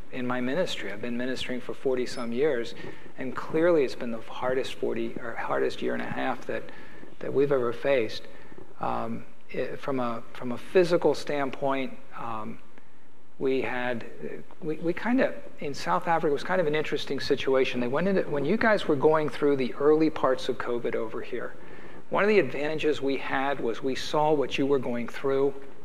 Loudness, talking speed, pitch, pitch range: -28 LUFS, 195 wpm, 135 Hz, 125-155 Hz